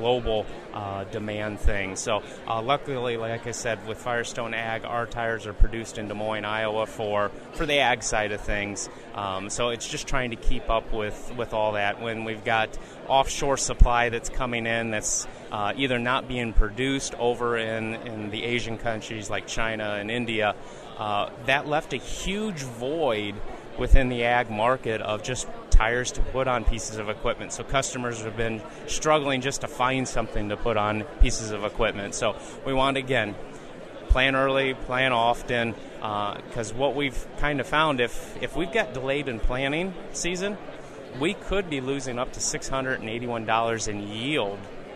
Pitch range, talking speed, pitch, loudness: 110-130 Hz, 175 wpm, 115 Hz, -27 LUFS